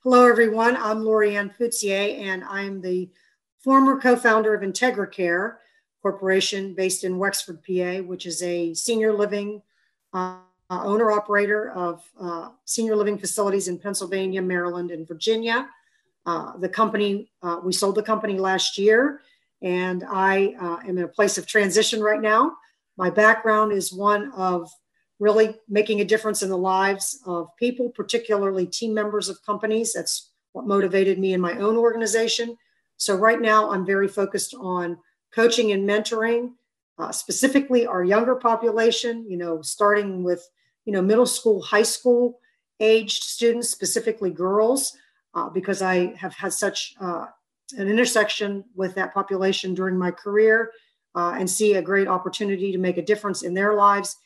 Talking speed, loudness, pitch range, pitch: 155 wpm, -22 LUFS, 185-225 Hz, 205 Hz